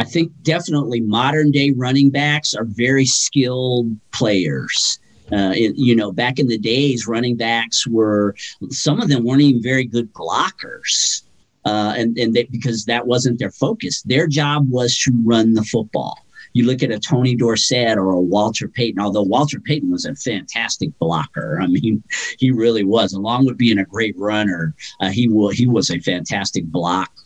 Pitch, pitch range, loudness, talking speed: 120 Hz, 110-130 Hz, -17 LUFS, 180 wpm